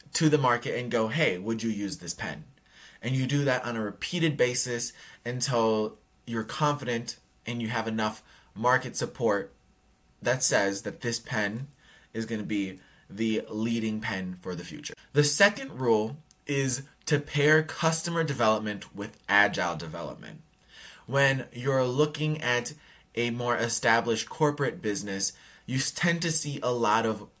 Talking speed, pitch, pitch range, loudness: 155 wpm, 120 Hz, 110-145 Hz, -28 LUFS